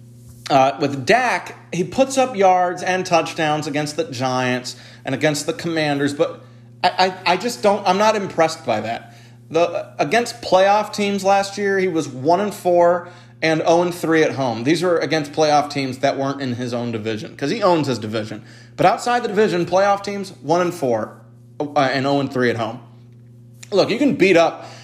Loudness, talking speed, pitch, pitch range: -19 LUFS, 195 wpm, 155 Hz, 125-180 Hz